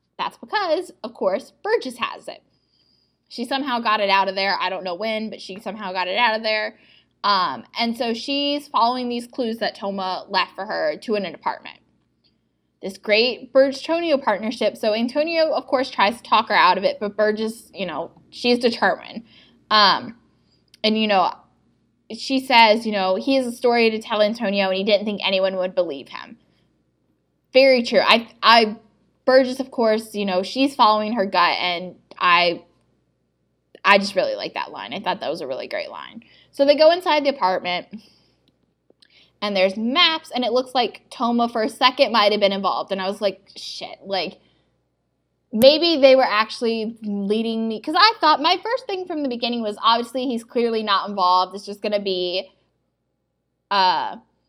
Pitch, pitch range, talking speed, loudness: 225 Hz, 195-265 Hz, 185 wpm, -20 LUFS